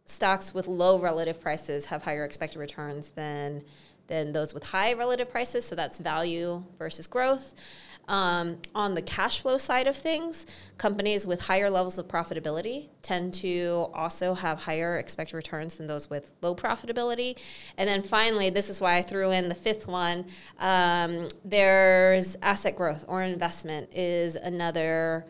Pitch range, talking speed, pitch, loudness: 160-195 Hz, 160 wpm, 175 Hz, -28 LUFS